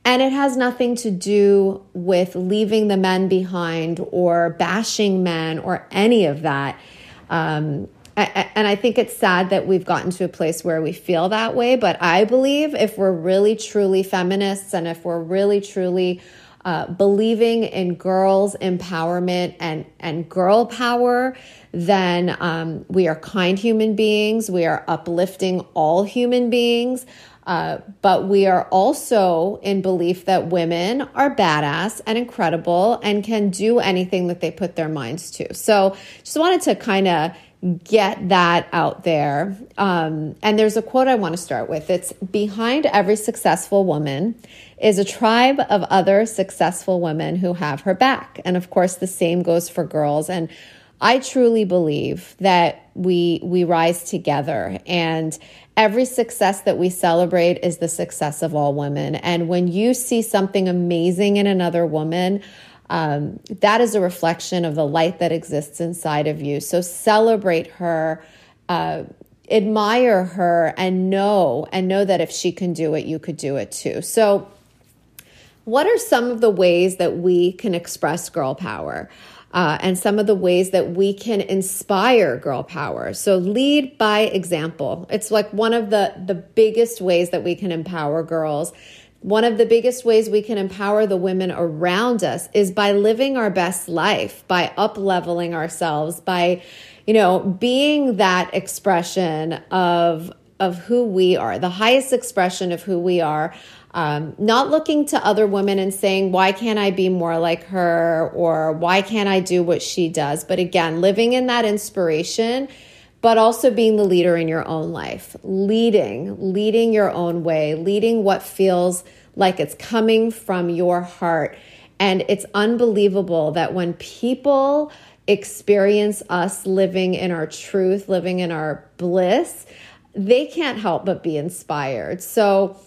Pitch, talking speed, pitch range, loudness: 185 Hz, 160 wpm, 170-215 Hz, -19 LUFS